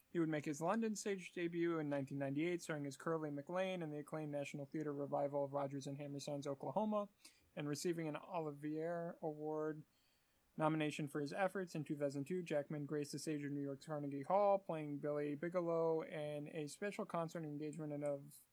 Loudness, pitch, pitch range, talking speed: -43 LUFS, 155 Hz, 145-170 Hz, 170 wpm